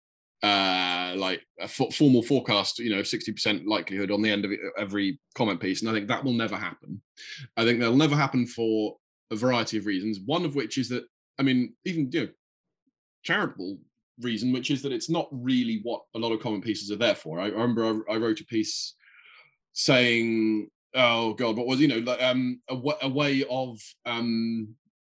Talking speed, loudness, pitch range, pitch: 205 wpm, -26 LUFS, 110-125 Hz, 115 Hz